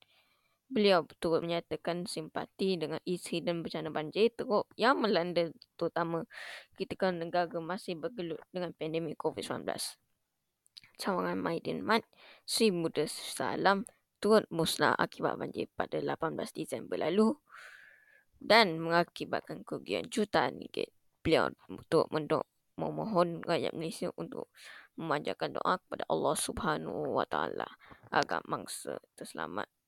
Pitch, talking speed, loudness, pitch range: 175 Hz, 110 wpm, -33 LUFS, 165-210 Hz